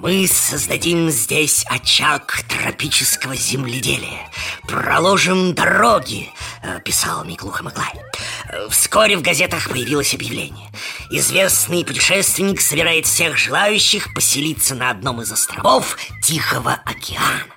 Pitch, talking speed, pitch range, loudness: 160 Hz, 95 wpm, 125-180 Hz, -16 LUFS